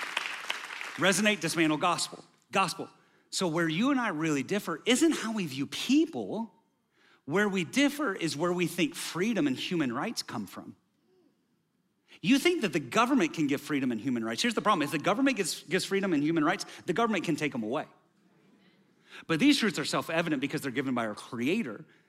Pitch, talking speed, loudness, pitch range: 185 Hz, 190 wpm, -29 LUFS, 155-230 Hz